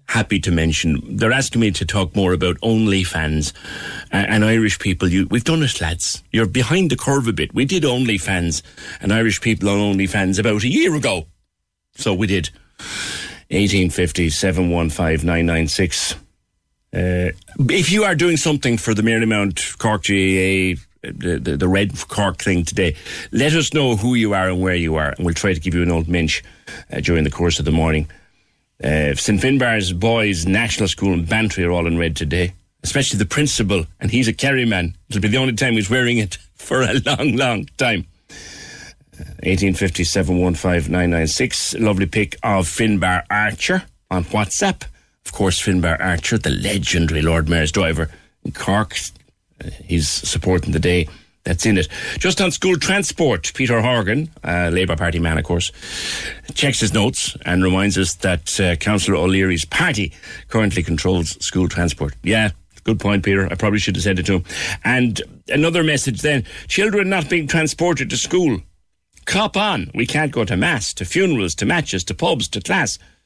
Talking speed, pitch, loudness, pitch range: 180 wpm, 95 Hz, -18 LUFS, 85-110 Hz